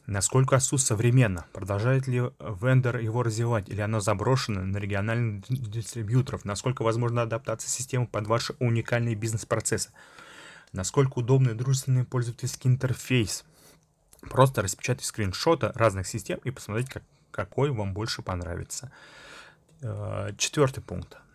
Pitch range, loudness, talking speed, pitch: 105-130 Hz, -27 LUFS, 110 wpm, 115 Hz